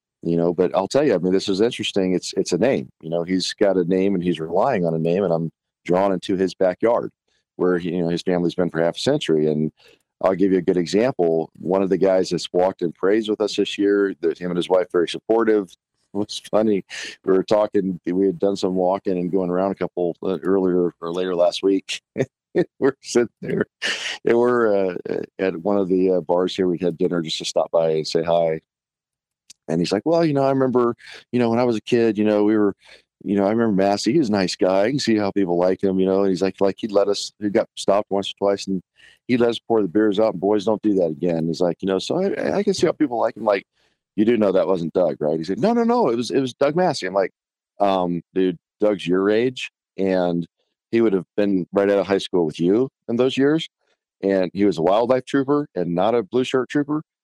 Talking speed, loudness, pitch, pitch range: 255 wpm, -21 LUFS, 95 Hz, 90-110 Hz